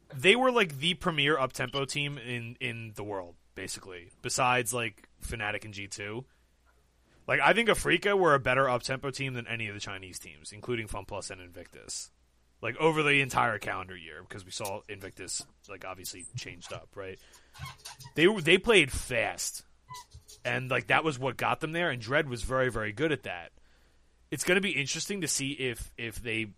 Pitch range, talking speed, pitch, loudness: 100-145 Hz, 190 wpm, 125 Hz, -29 LUFS